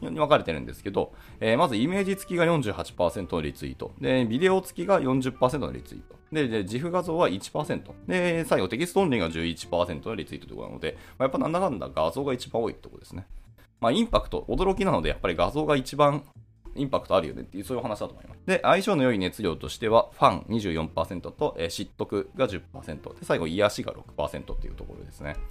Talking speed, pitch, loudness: 420 characters per minute, 115 Hz, -27 LUFS